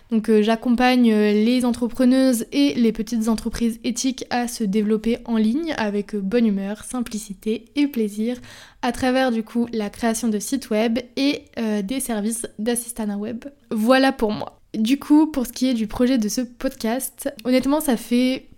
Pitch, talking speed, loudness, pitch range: 235 Hz, 170 wpm, -21 LUFS, 220-255 Hz